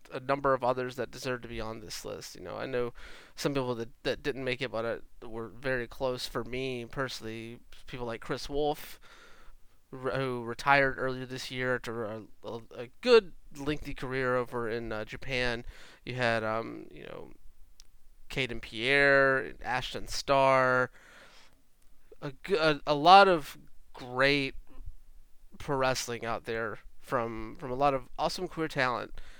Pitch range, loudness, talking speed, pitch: 120-140 Hz, -30 LUFS, 155 wpm, 130 Hz